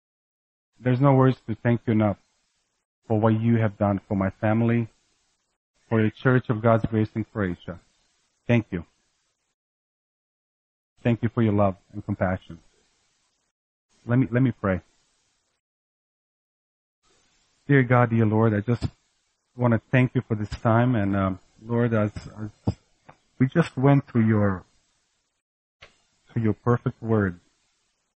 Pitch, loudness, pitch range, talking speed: 110 Hz, -24 LUFS, 100-120 Hz, 135 wpm